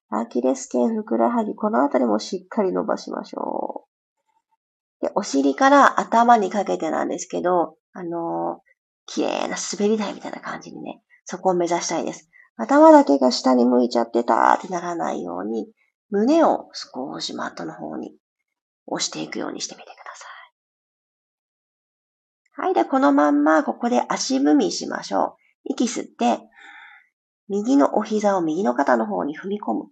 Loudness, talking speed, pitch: -21 LUFS, 315 characters per minute, 195 Hz